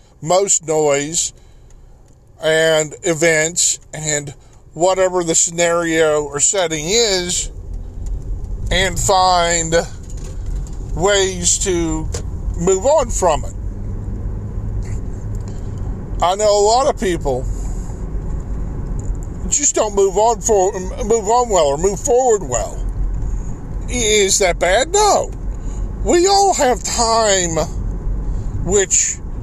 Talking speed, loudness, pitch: 95 wpm, -16 LUFS, 155 Hz